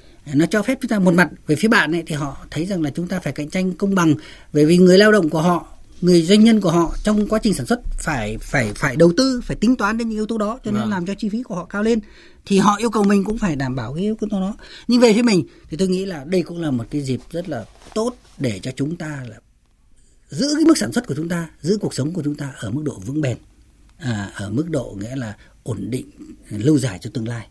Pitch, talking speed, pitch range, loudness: 170 Hz, 285 wpm, 145-210 Hz, -19 LUFS